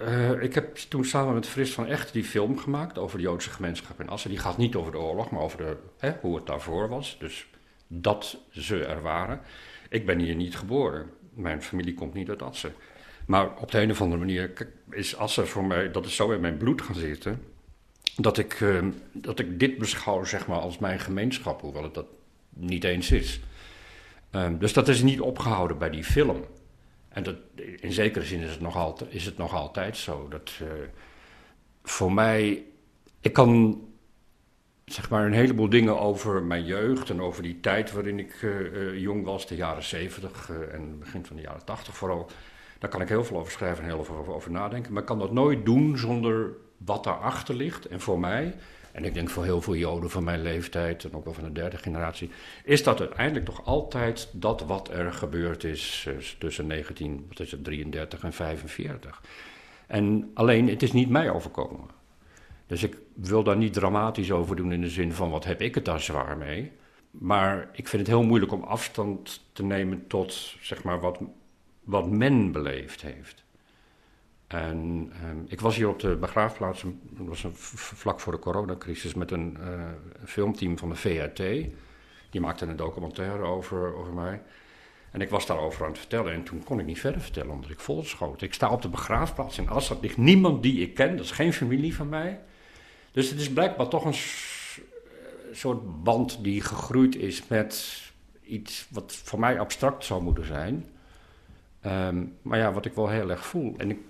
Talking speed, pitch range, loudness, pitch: 195 wpm, 85-115 Hz, -28 LUFS, 95 Hz